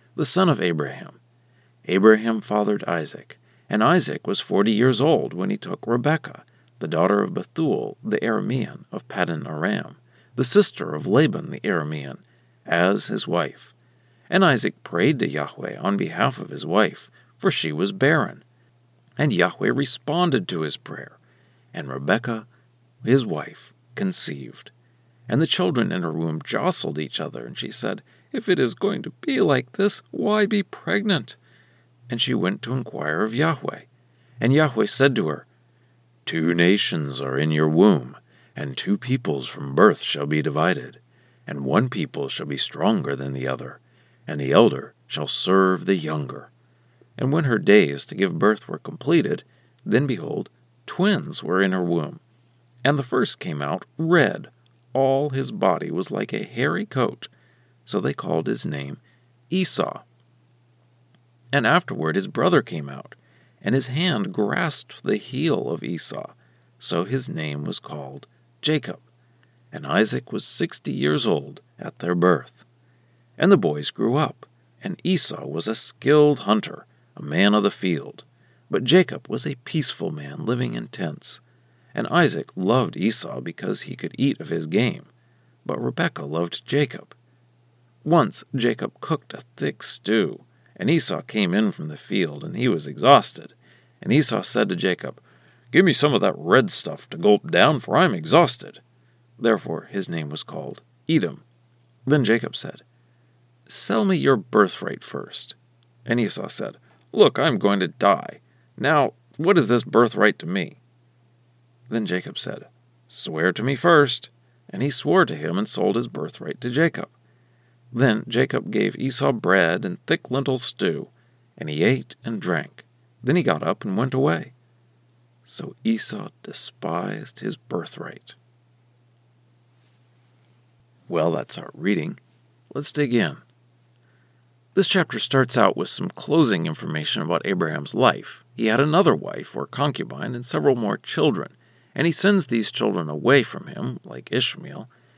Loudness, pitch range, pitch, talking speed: -22 LUFS, 85-135 Hz, 120 Hz, 155 wpm